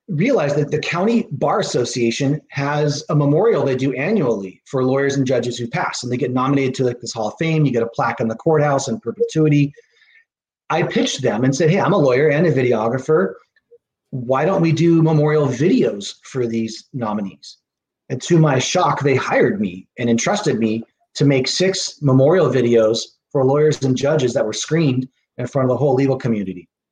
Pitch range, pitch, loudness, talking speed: 120-155 Hz, 135 Hz, -18 LUFS, 195 wpm